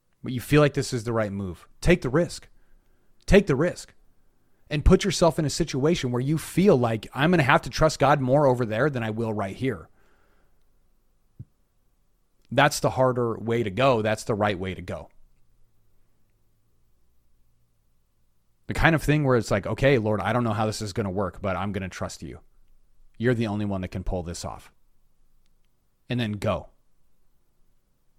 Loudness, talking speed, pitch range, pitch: -24 LUFS, 185 wpm, 95-135 Hz, 110 Hz